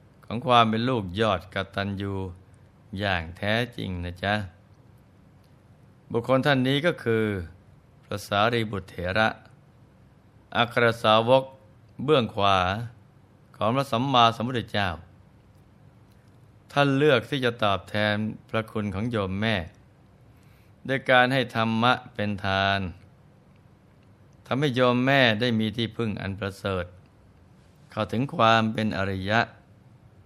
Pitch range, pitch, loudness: 100-125 Hz, 110 Hz, -25 LUFS